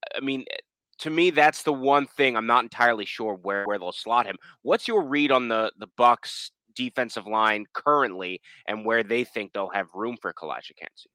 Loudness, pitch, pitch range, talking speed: -25 LUFS, 115 Hz, 110-135 Hz, 195 wpm